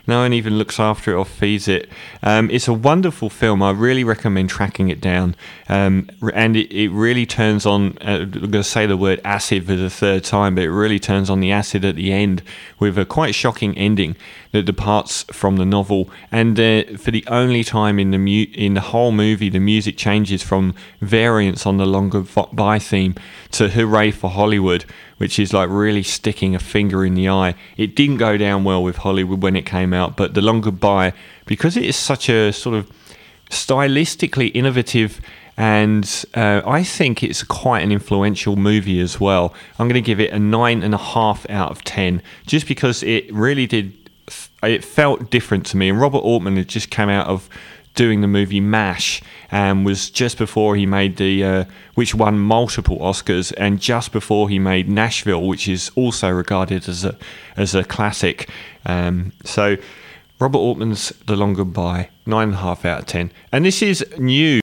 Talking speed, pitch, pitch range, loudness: 195 wpm, 105 Hz, 95-110 Hz, -17 LUFS